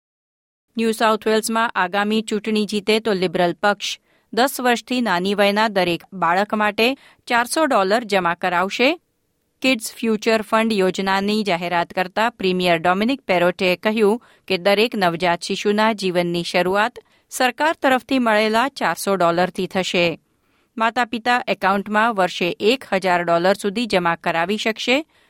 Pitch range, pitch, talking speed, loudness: 185-225 Hz, 210 Hz, 120 wpm, -19 LUFS